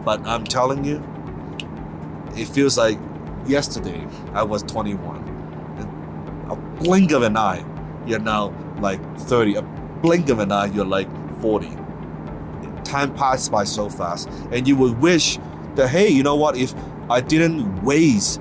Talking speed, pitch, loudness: 150 wpm, 110 Hz, -20 LUFS